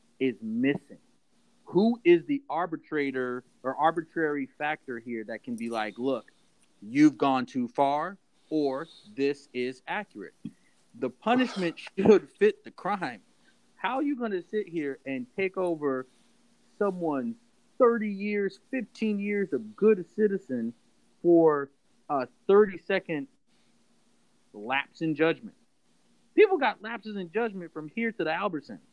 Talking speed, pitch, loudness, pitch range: 135 wpm, 185 Hz, -28 LUFS, 140-220 Hz